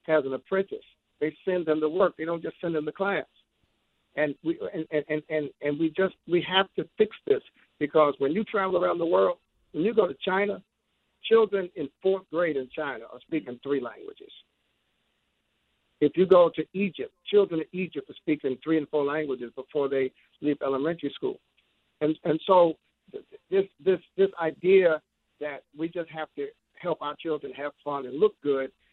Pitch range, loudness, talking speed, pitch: 145-190 Hz, -27 LUFS, 190 wpm, 160 Hz